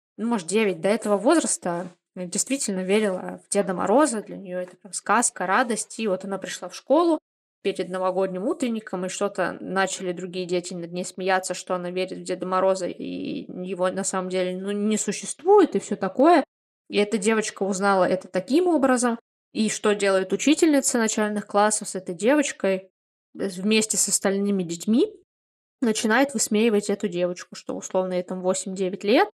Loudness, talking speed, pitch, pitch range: -24 LUFS, 165 wpm, 200 Hz, 185-225 Hz